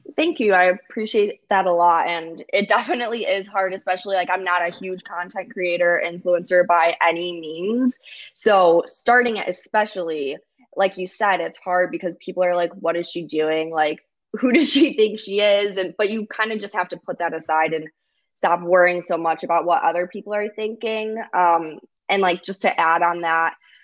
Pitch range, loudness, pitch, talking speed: 170-210 Hz, -20 LUFS, 185 Hz, 195 wpm